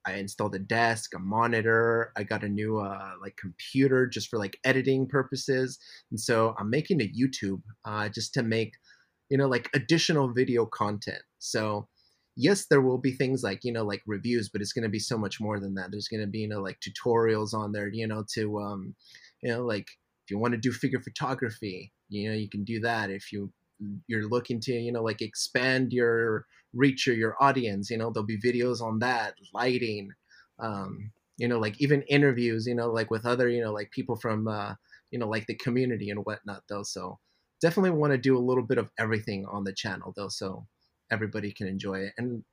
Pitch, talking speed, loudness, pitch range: 110 Hz, 215 wpm, -29 LUFS, 105-125 Hz